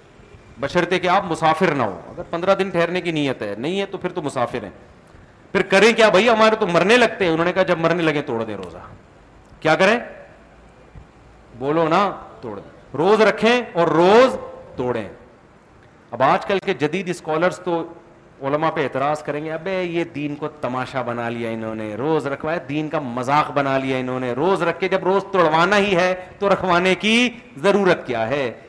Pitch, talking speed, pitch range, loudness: 170 Hz, 195 wpm, 145-190 Hz, -19 LUFS